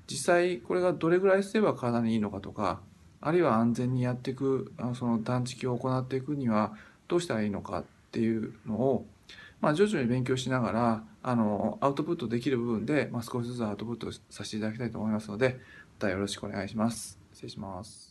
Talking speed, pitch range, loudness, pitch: 435 characters per minute, 105-130 Hz, -30 LUFS, 115 Hz